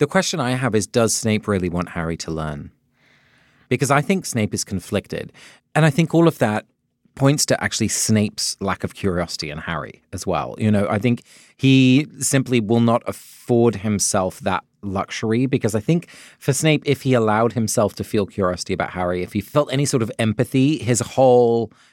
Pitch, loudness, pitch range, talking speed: 115 Hz, -20 LUFS, 100-135 Hz, 190 wpm